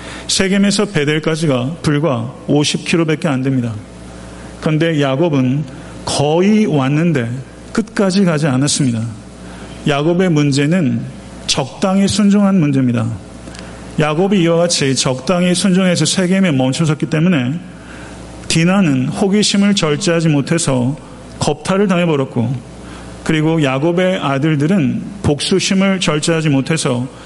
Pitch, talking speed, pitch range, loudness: 150 Hz, 275 characters per minute, 130-180 Hz, -14 LUFS